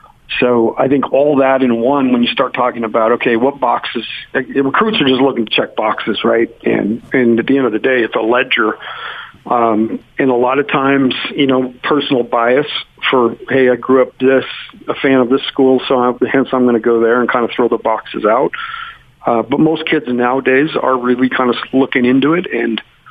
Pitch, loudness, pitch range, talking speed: 130 Hz, -13 LUFS, 120-135 Hz, 215 wpm